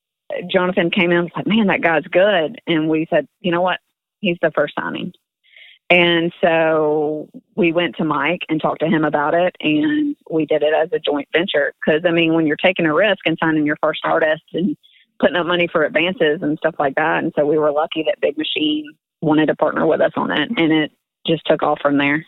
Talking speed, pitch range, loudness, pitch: 230 wpm, 155-180 Hz, -18 LUFS, 165 Hz